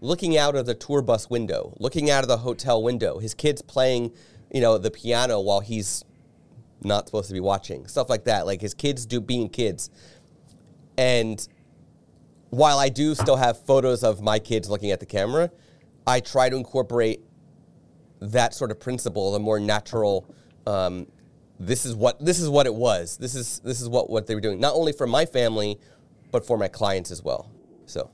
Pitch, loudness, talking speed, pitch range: 120 Hz, -24 LUFS, 195 wpm, 110-130 Hz